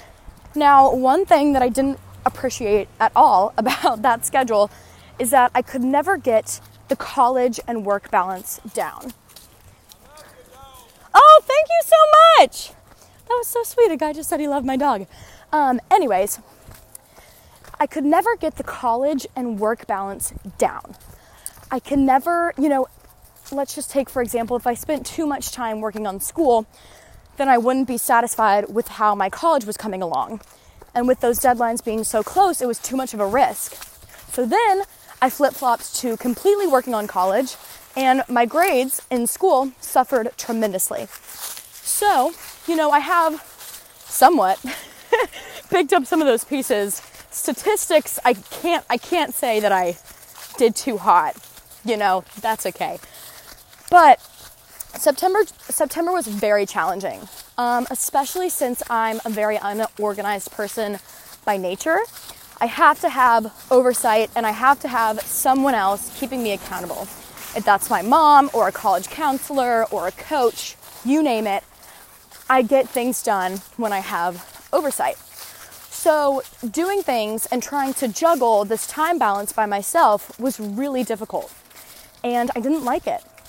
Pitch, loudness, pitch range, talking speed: 255 Hz, -19 LUFS, 220-295 Hz, 155 wpm